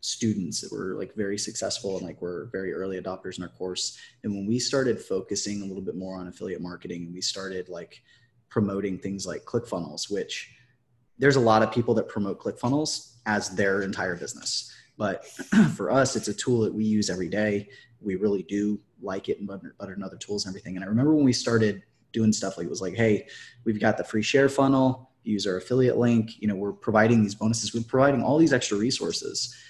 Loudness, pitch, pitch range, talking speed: -26 LUFS, 110 Hz, 100-120 Hz, 215 wpm